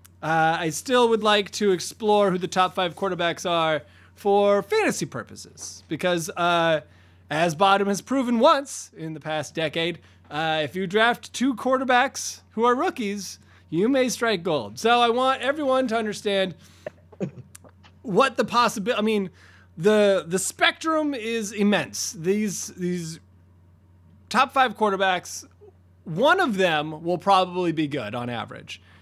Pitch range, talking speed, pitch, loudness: 155-230 Hz, 145 wpm, 190 Hz, -23 LUFS